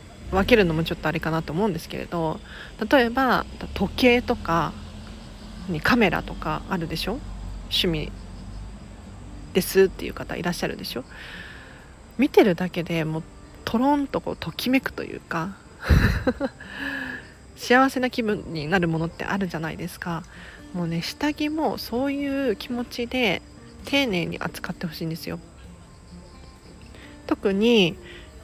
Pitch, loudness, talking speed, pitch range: 175 Hz, -24 LUFS, 275 characters per minute, 150-245 Hz